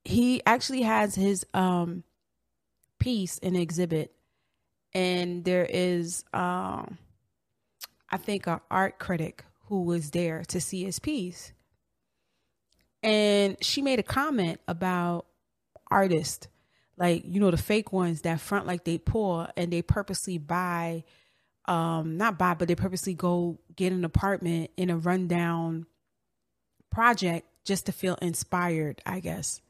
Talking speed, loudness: 135 wpm, -28 LUFS